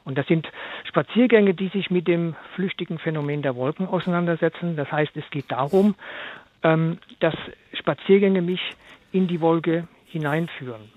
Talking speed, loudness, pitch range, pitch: 135 wpm, -23 LUFS, 155-190 Hz, 170 Hz